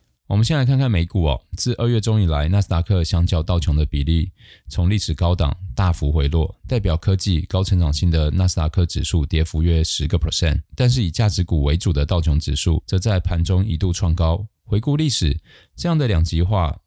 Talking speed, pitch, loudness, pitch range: 330 characters per minute, 90 Hz, -20 LUFS, 80-100 Hz